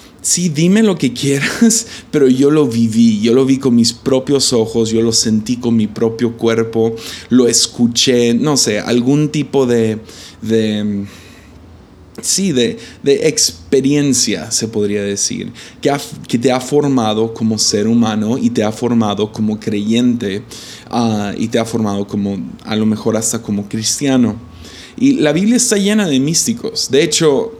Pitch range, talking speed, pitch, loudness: 110-135 Hz, 160 wpm, 115 Hz, -14 LUFS